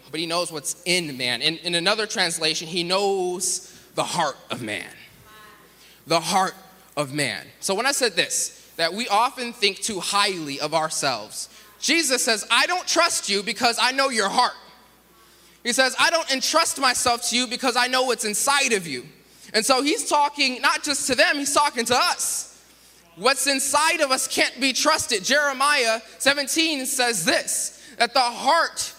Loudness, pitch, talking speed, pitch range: -21 LUFS, 235 Hz, 175 wpm, 185-275 Hz